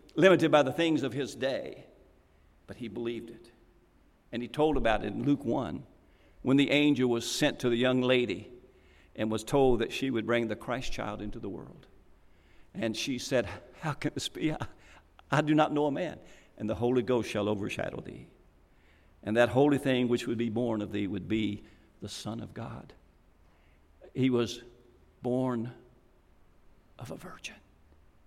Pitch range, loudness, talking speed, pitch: 95-130 Hz, -30 LUFS, 180 wpm, 115 Hz